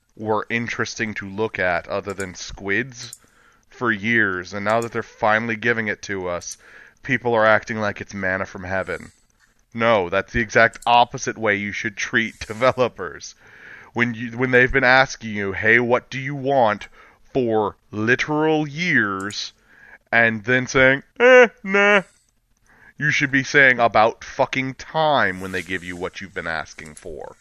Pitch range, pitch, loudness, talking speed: 105-130 Hz, 115 Hz, -20 LUFS, 160 wpm